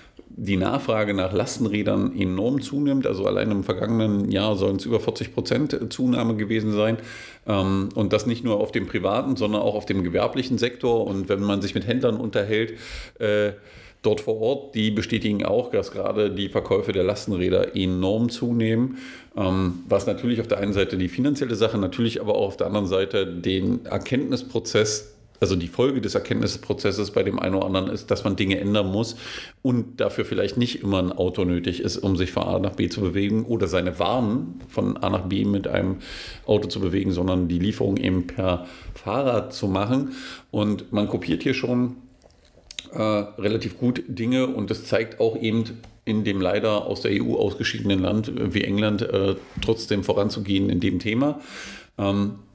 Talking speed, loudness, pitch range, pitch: 175 wpm, -24 LUFS, 95-115 Hz, 105 Hz